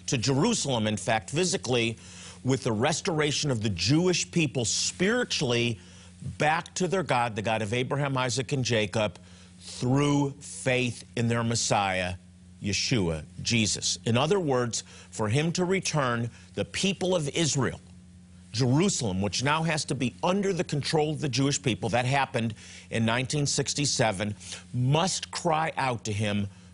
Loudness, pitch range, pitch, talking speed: -27 LUFS, 105-145 Hz, 125 Hz, 145 wpm